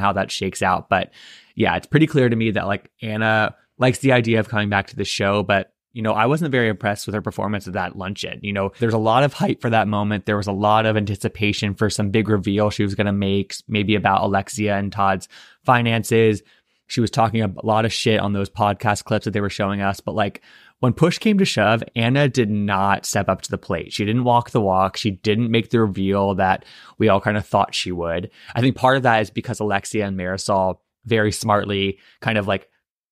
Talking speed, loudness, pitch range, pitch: 235 wpm, -20 LUFS, 100-115 Hz, 105 Hz